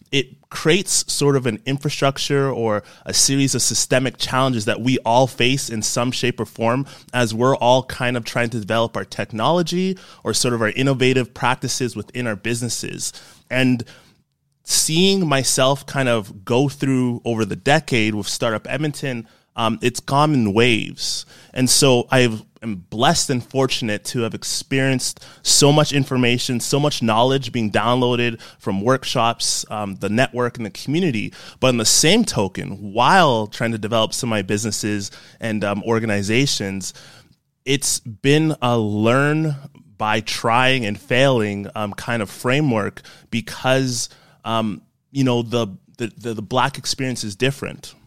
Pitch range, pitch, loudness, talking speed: 110-135 Hz, 125 Hz, -19 LUFS, 150 wpm